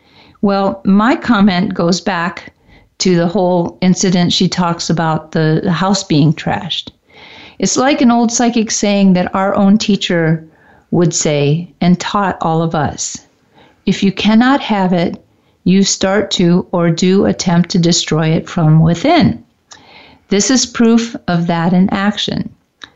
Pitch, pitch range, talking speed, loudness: 185 Hz, 170-205 Hz, 145 wpm, -13 LUFS